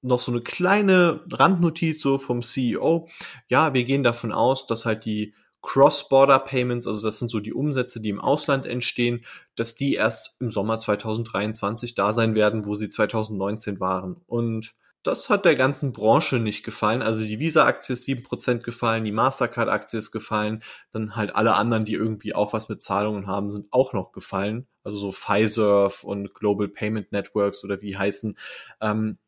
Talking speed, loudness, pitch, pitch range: 170 wpm, -23 LUFS, 110 Hz, 105-125 Hz